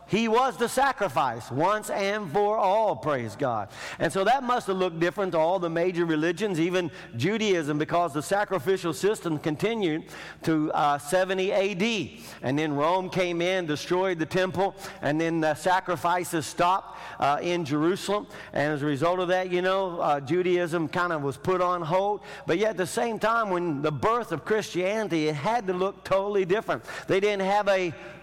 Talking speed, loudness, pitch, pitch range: 185 wpm, -26 LUFS, 185 Hz, 165-200 Hz